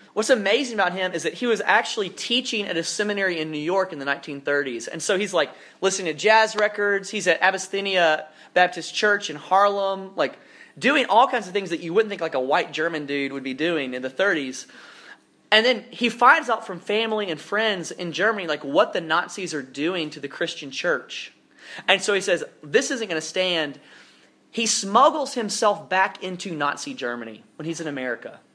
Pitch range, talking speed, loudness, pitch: 155-215 Hz, 200 wpm, -22 LUFS, 185 Hz